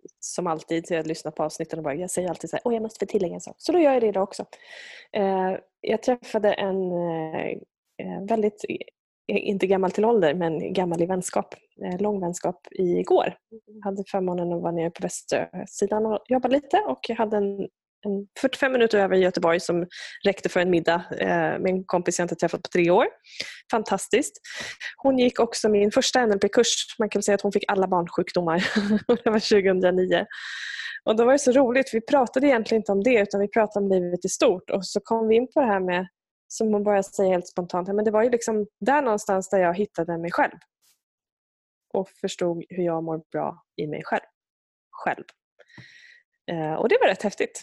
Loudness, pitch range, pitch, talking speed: -24 LUFS, 180-225 Hz, 200 Hz, 190 wpm